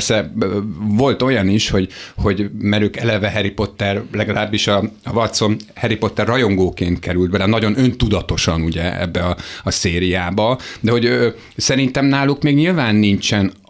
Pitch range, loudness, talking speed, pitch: 95-115 Hz, -17 LUFS, 140 wpm, 105 Hz